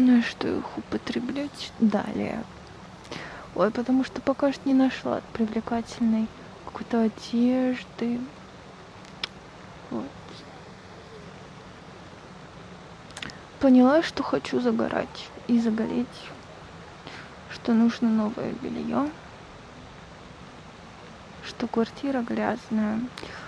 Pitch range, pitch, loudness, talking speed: 225-255 Hz, 235 Hz, -26 LUFS, 75 wpm